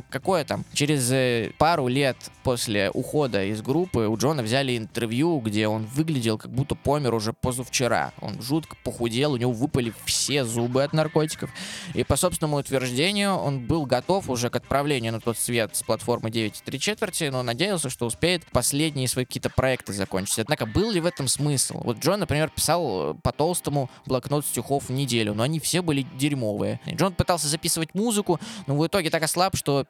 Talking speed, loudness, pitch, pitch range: 180 wpm, -25 LUFS, 135 Hz, 120-160 Hz